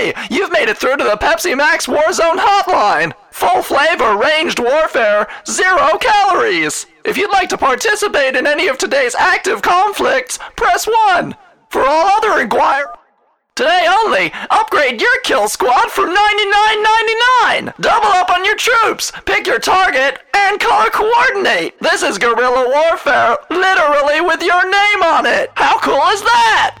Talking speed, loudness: 150 wpm, -12 LUFS